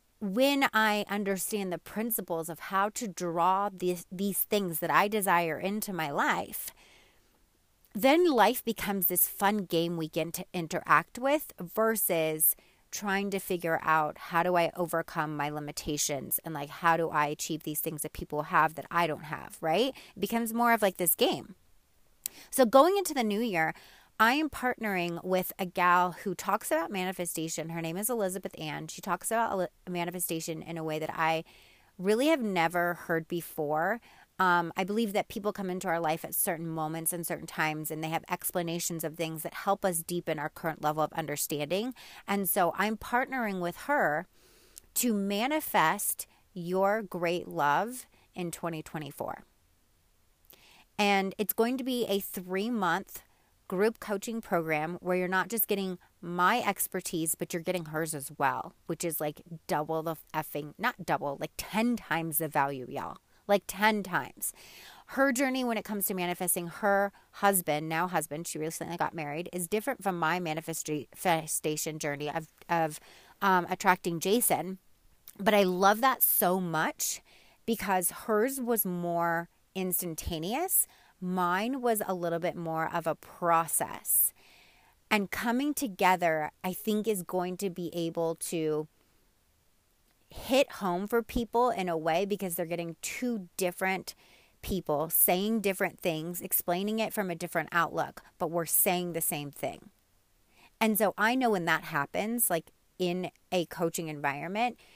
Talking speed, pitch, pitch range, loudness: 160 wpm, 180 Hz, 165-205 Hz, -30 LUFS